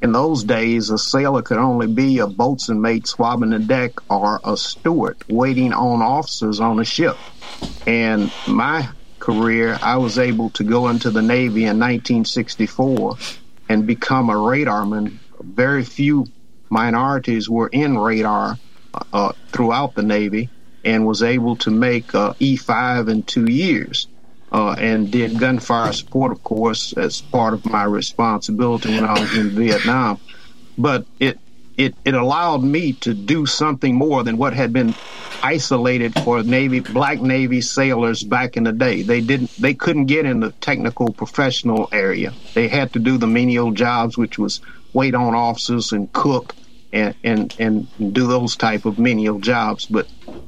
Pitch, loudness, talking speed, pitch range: 120 Hz, -18 LUFS, 160 wpm, 110-125 Hz